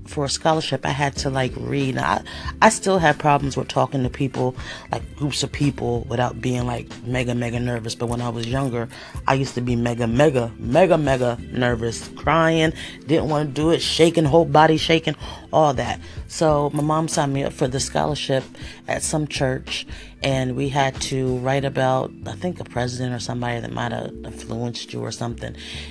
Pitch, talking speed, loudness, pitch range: 130 Hz, 195 wpm, -21 LUFS, 120-150 Hz